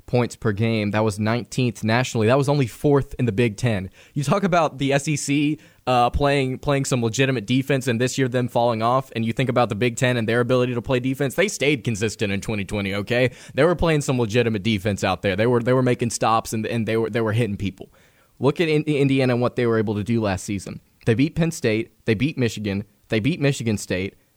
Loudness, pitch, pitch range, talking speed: -22 LUFS, 120 Hz, 110-135 Hz, 240 wpm